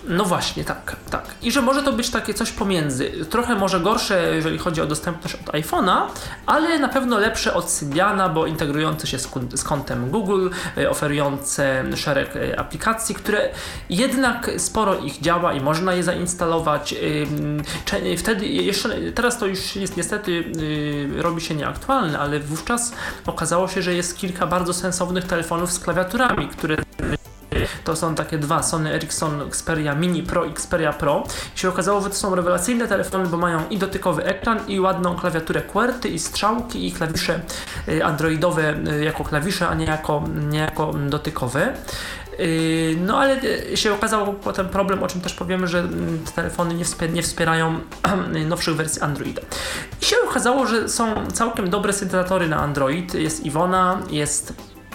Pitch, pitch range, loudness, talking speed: 175 Hz, 155-195 Hz, -21 LUFS, 155 wpm